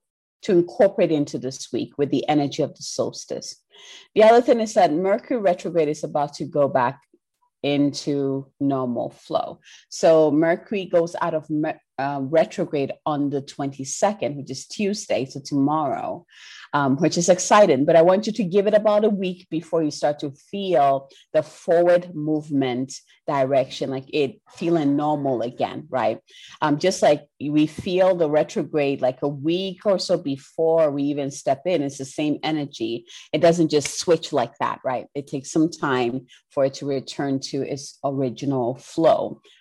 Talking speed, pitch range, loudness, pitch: 170 wpm, 140-175 Hz, -22 LUFS, 150 Hz